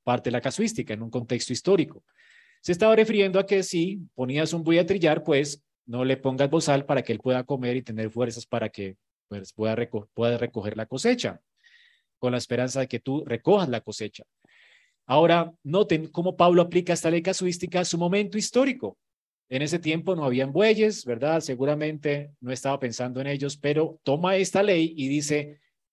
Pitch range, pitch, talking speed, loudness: 125-185 Hz, 150 Hz, 185 wpm, -25 LUFS